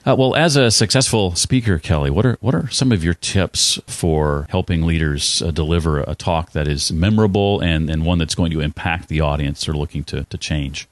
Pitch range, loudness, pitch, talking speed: 75-105 Hz, -18 LUFS, 85 Hz, 215 wpm